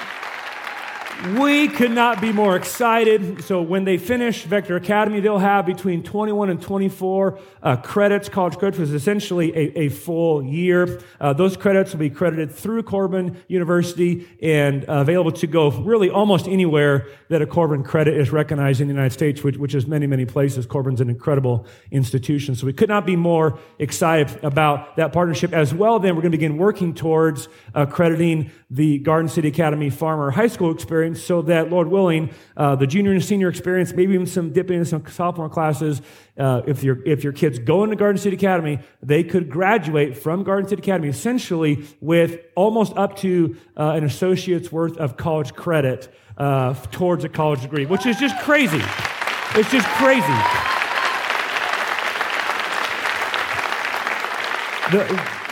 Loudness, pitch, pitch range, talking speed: -20 LUFS, 165 Hz, 150-190 Hz, 170 wpm